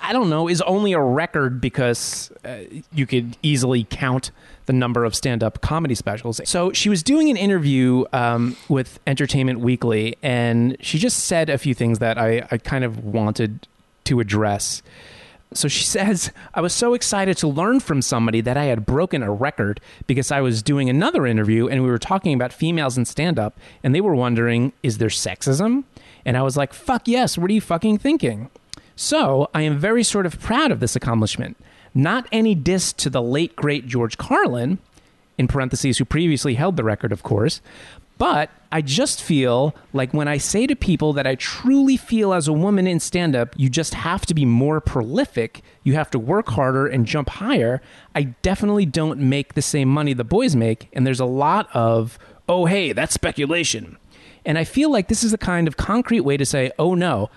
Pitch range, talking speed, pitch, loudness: 120-175 Hz, 200 wpm, 140 Hz, -20 LUFS